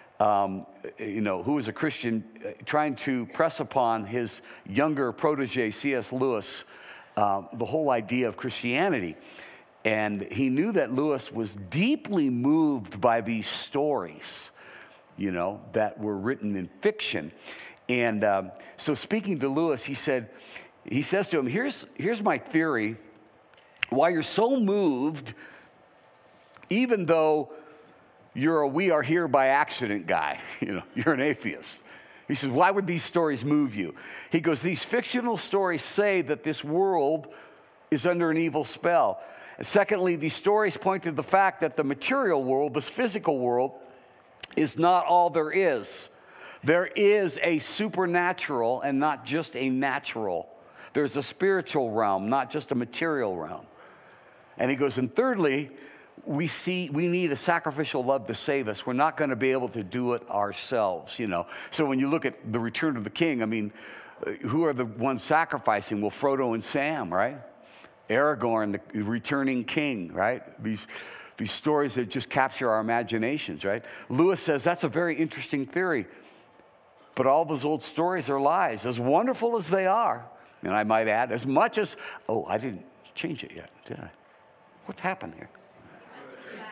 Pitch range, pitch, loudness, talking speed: 125-170 Hz, 145 Hz, -27 LUFS, 165 wpm